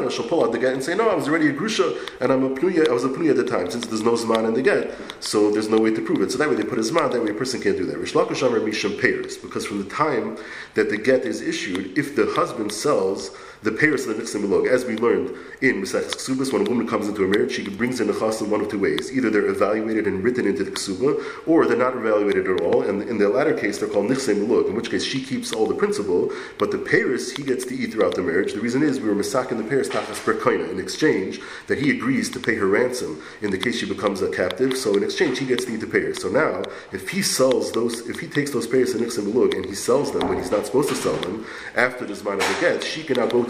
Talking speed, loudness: 275 wpm, -22 LUFS